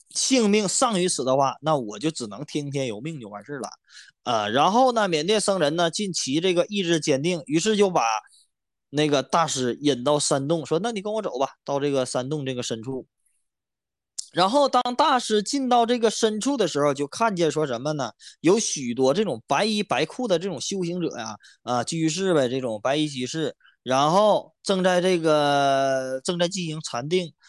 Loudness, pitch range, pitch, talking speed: -23 LUFS, 140-200 Hz, 160 Hz, 275 characters per minute